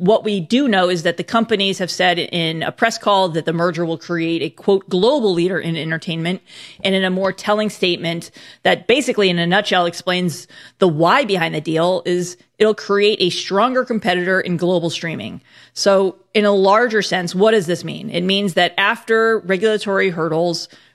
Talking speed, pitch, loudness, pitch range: 190 wpm, 185 Hz, -17 LUFS, 175-205 Hz